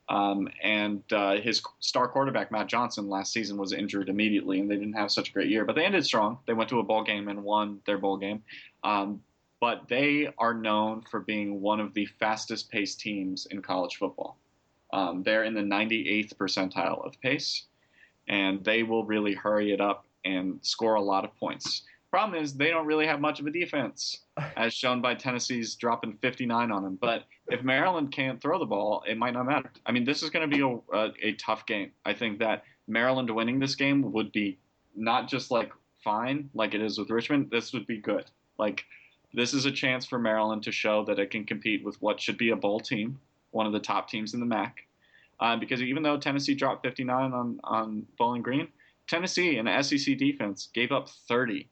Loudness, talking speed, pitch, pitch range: -29 LUFS, 210 wpm, 110 Hz, 105-130 Hz